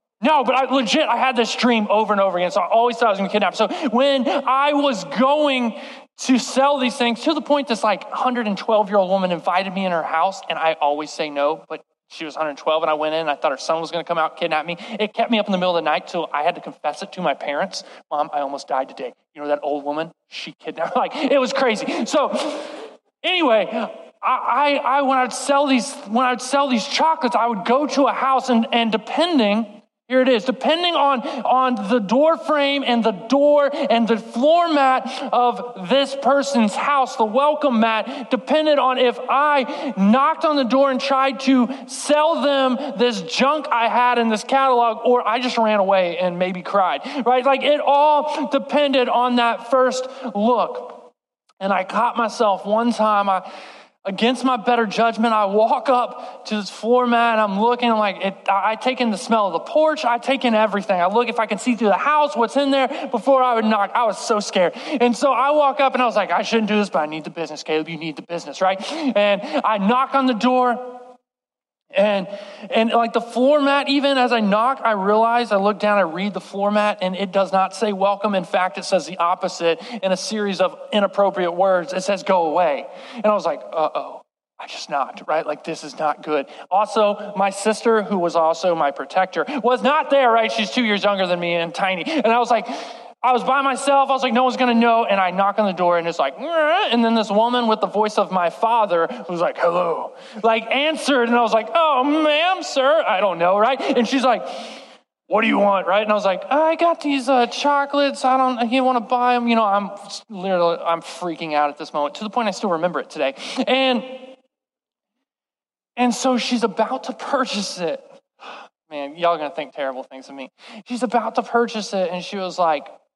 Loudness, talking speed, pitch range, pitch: -19 LUFS, 230 wpm, 195-265 Hz, 235 Hz